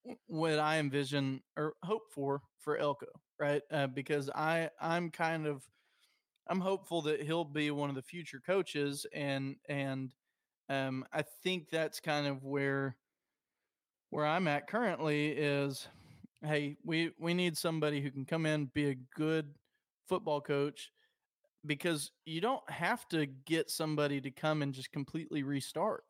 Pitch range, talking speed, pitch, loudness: 140-165 Hz, 150 wpm, 150 Hz, -36 LUFS